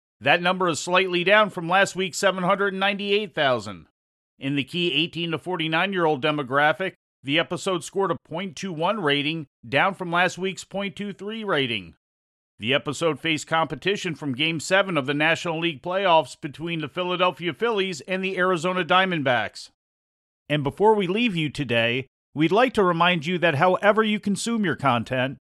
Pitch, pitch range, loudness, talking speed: 170 Hz, 145-190 Hz, -23 LUFS, 155 wpm